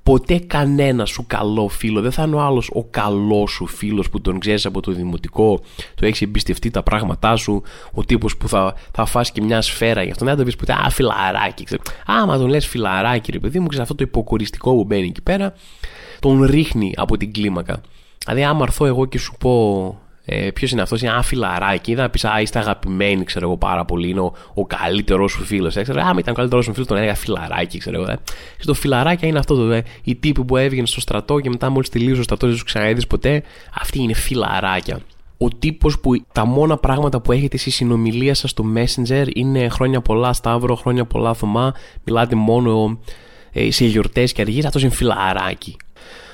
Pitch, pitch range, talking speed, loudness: 115 Hz, 105-130 Hz, 210 wpm, -18 LUFS